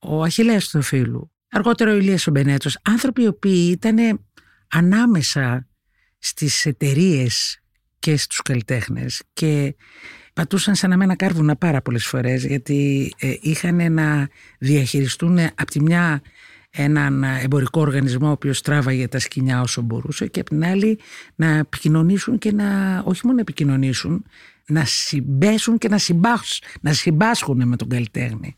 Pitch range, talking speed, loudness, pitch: 135-185 Hz, 135 wpm, -19 LUFS, 150 Hz